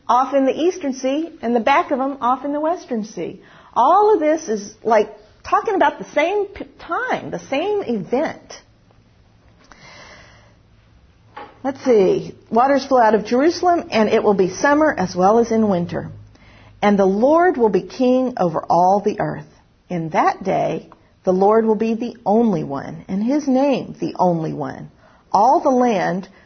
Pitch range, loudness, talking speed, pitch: 205-285 Hz, -18 LUFS, 170 wpm, 240 Hz